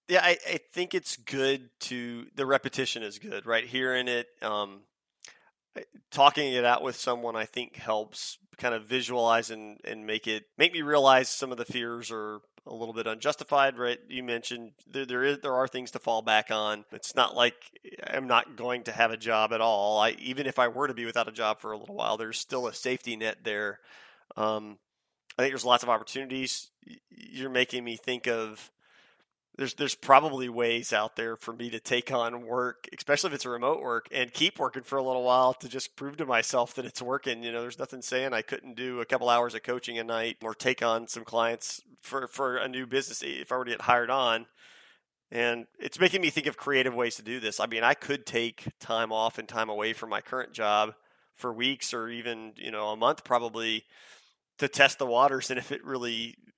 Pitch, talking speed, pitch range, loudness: 120 Hz, 220 wpm, 115-130 Hz, -29 LUFS